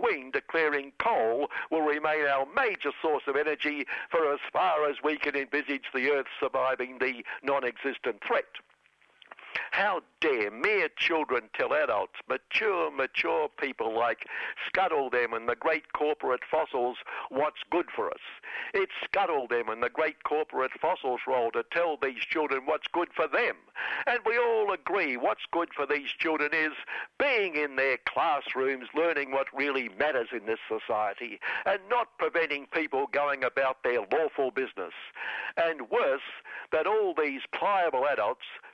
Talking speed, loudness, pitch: 150 wpm, -29 LUFS, 150 Hz